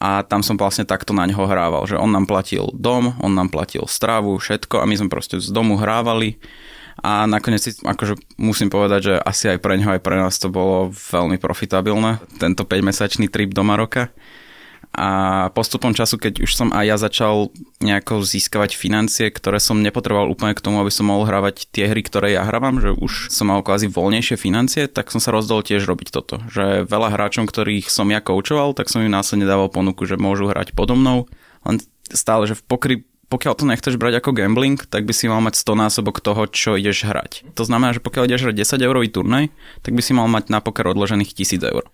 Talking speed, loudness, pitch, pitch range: 210 wpm, -18 LUFS, 105 Hz, 100-115 Hz